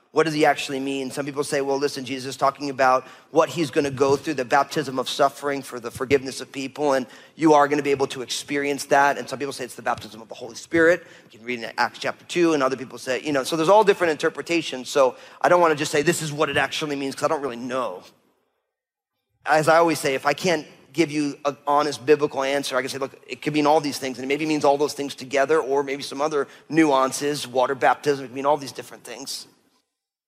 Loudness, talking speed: -22 LUFS, 255 wpm